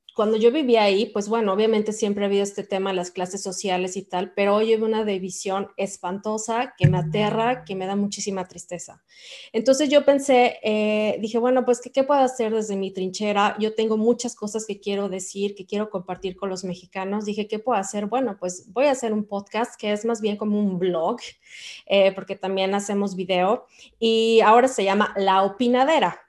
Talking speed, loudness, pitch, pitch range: 200 wpm, -22 LUFS, 210 Hz, 195-225 Hz